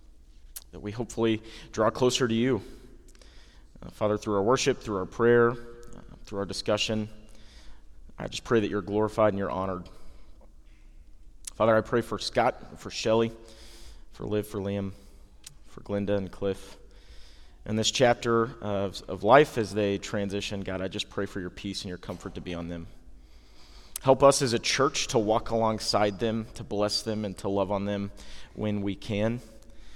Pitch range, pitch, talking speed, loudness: 95-110 Hz, 105 Hz, 170 wpm, -27 LUFS